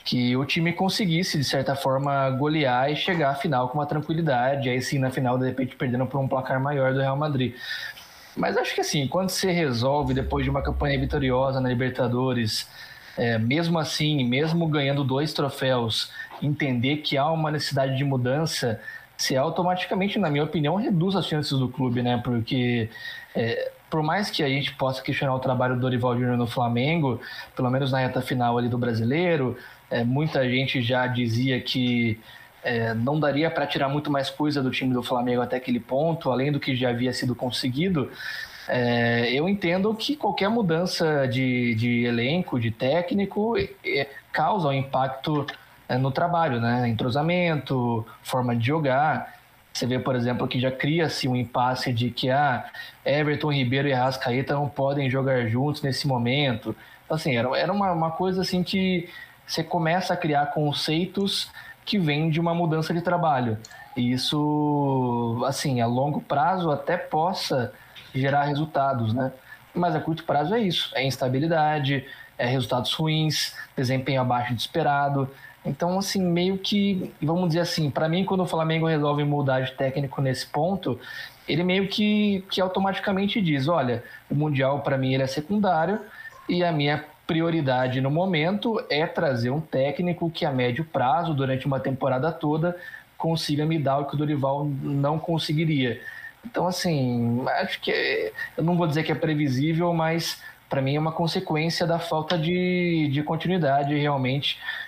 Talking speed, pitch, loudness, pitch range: 170 wpm, 145 Hz, -25 LUFS, 130-170 Hz